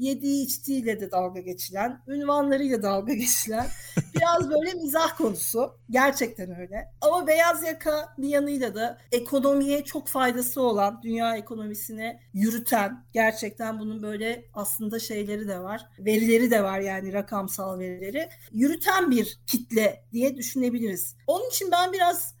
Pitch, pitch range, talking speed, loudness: 235 Hz, 215-280 Hz, 130 wpm, -26 LUFS